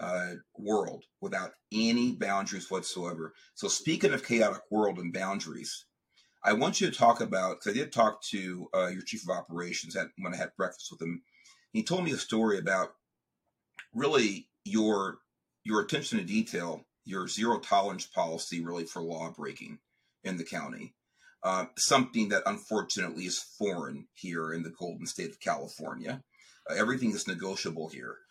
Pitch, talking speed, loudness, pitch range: 95 Hz, 165 wpm, -32 LUFS, 85-120 Hz